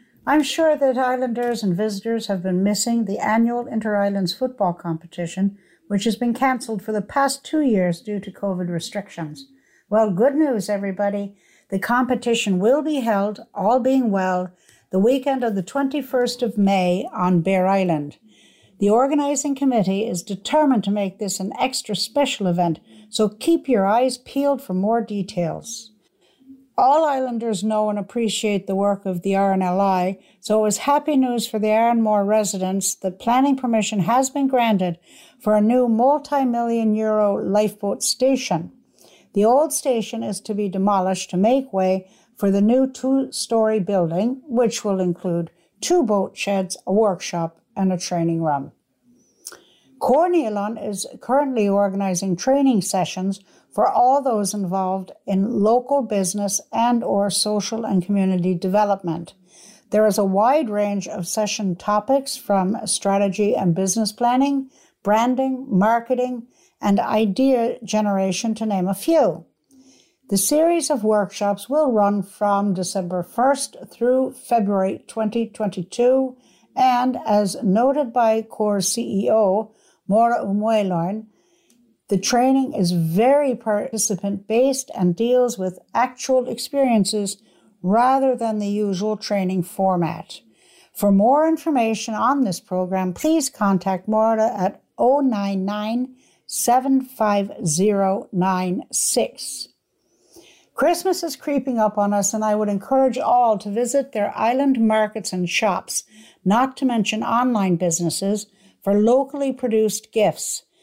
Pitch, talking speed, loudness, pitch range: 215 Hz, 130 wpm, -20 LUFS, 195-250 Hz